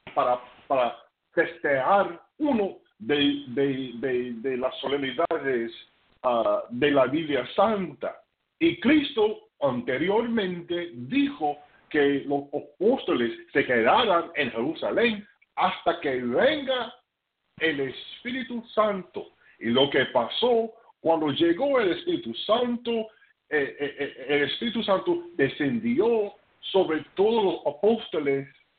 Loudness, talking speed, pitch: -26 LUFS, 105 wpm, 195 Hz